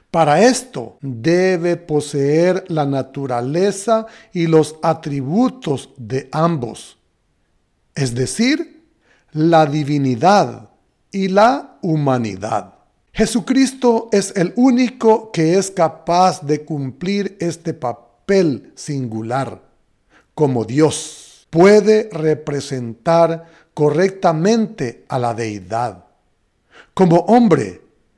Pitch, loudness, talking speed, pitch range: 160 Hz, -17 LUFS, 85 wpm, 135-195 Hz